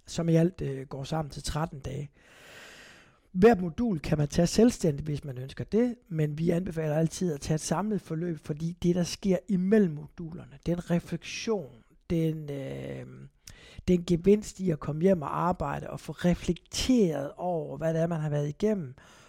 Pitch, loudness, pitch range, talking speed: 165 Hz, -29 LUFS, 150-180 Hz, 175 wpm